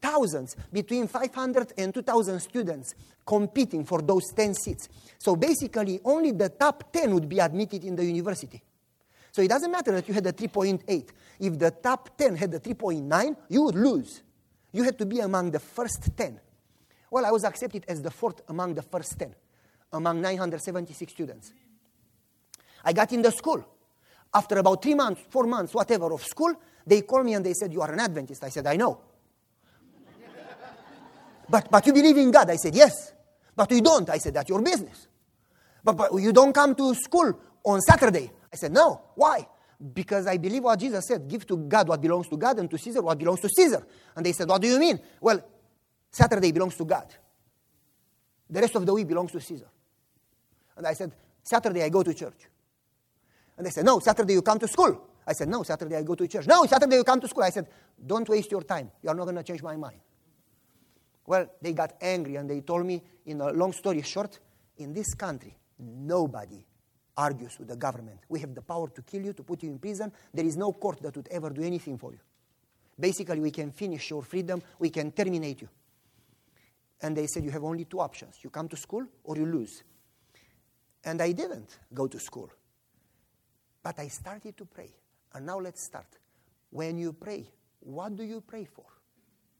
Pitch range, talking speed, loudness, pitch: 155-220 Hz, 200 wpm, -26 LUFS, 180 Hz